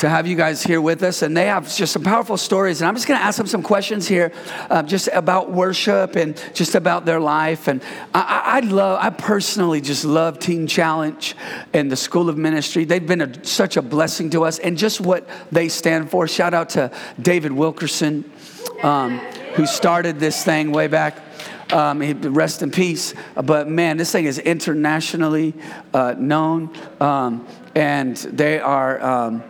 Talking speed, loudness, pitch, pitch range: 185 wpm, -19 LUFS, 165 Hz, 155-180 Hz